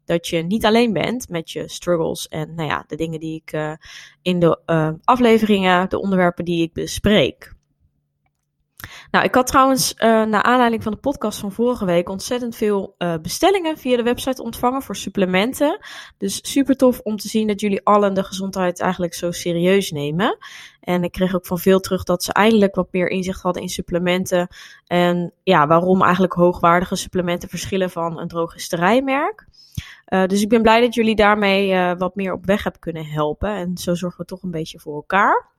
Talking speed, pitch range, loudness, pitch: 190 wpm, 175-220 Hz, -19 LUFS, 185 Hz